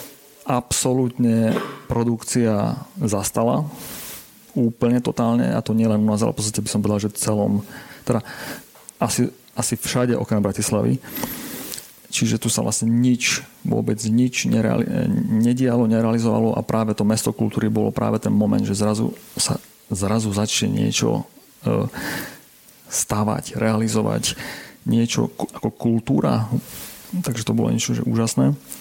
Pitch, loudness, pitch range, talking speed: 115 Hz, -21 LUFS, 105-120 Hz, 125 wpm